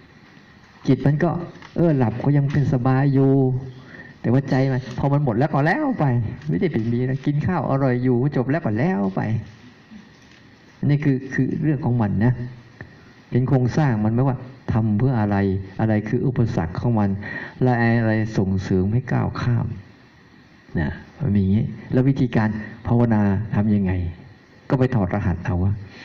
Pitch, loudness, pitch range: 125 Hz, -21 LUFS, 110-135 Hz